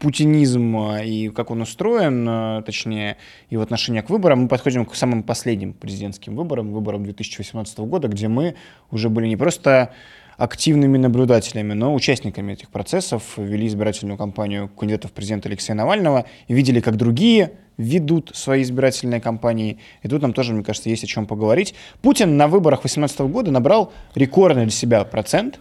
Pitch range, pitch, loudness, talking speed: 110-135 Hz, 115 Hz, -19 LUFS, 160 wpm